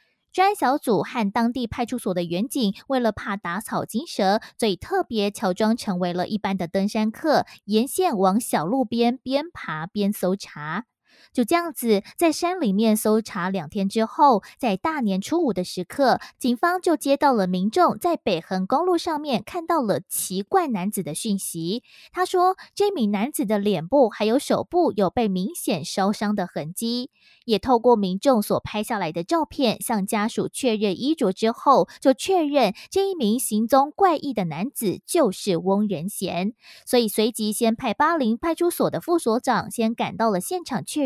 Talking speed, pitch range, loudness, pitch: 255 characters per minute, 200-280 Hz, -23 LUFS, 225 Hz